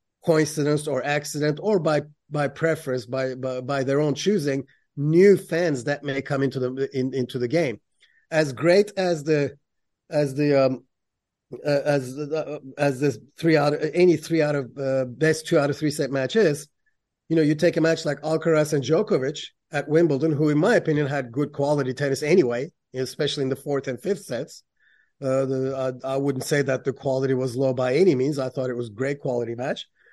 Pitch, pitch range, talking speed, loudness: 145 Hz, 130-155 Hz, 200 wpm, -23 LUFS